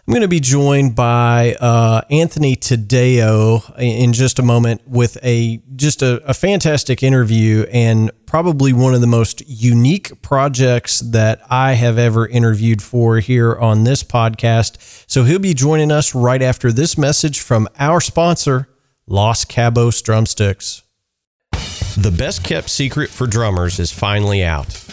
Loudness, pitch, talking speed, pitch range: -14 LUFS, 120 Hz, 150 wpm, 110-135 Hz